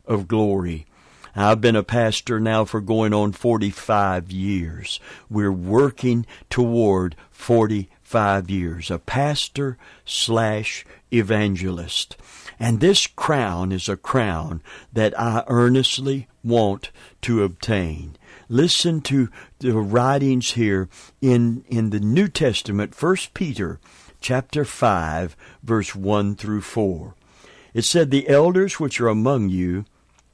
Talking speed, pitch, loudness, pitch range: 115 wpm, 110 Hz, -21 LUFS, 95-125 Hz